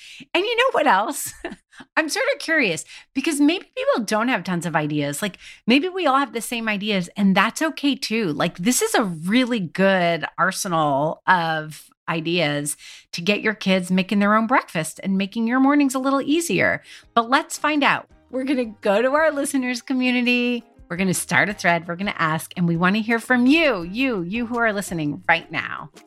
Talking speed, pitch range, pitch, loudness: 205 wpm, 180-270 Hz, 220 Hz, -21 LUFS